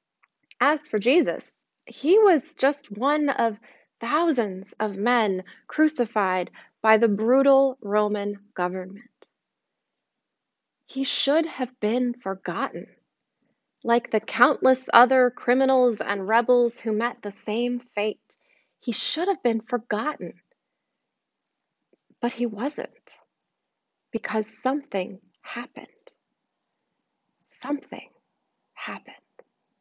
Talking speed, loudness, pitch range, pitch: 95 wpm, -24 LUFS, 215-270 Hz, 240 Hz